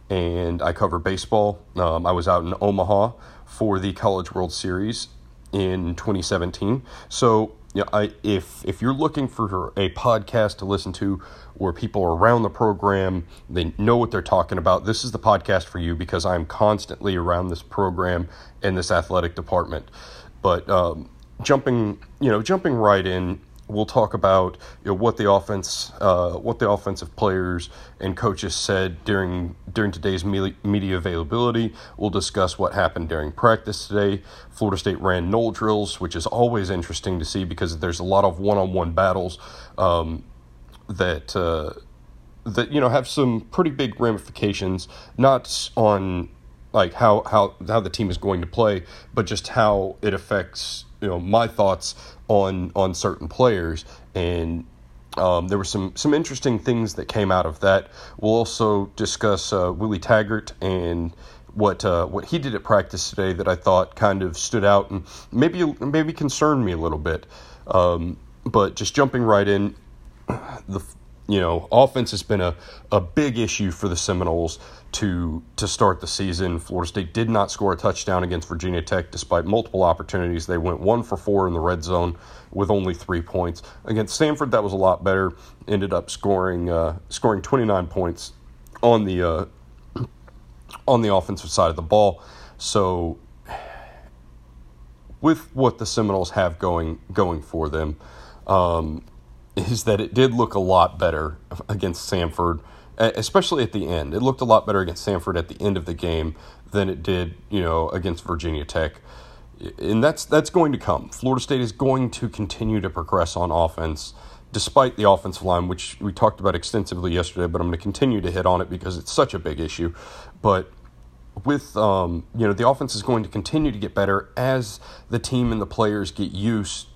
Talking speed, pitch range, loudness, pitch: 180 wpm, 85-105 Hz, -22 LUFS, 95 Hz